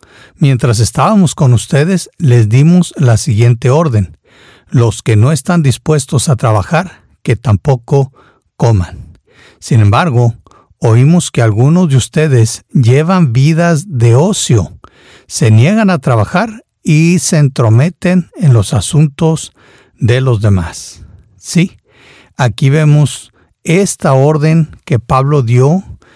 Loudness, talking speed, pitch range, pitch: -10 LUFS, 115 wpm, 115-160 Hz, 130 Hz